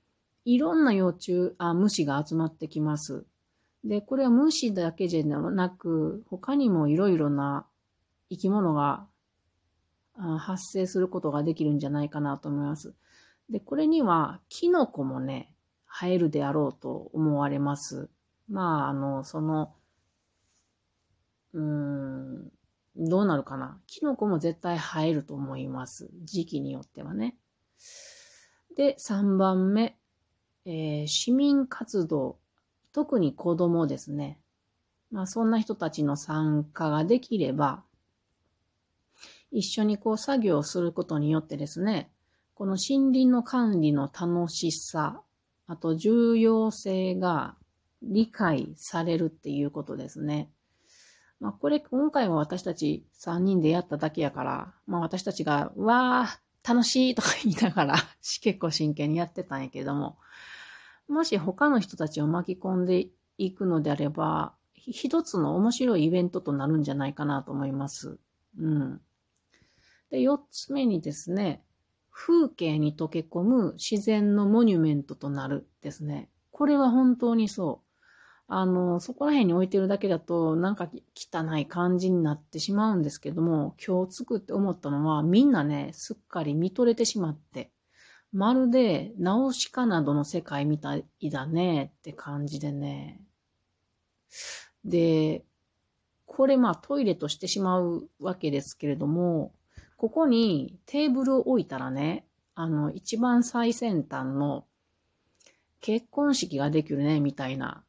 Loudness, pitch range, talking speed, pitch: -27 LUFS, 145-215 Hz, 265 characters per minute, 170 Hz